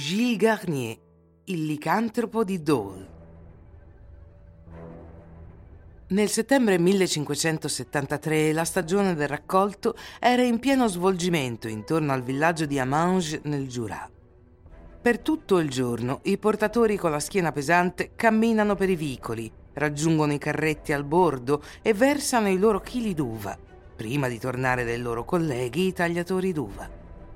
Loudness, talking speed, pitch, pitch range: -25 LUFS, 125 wpm, 150 Hz, 115-190 Hz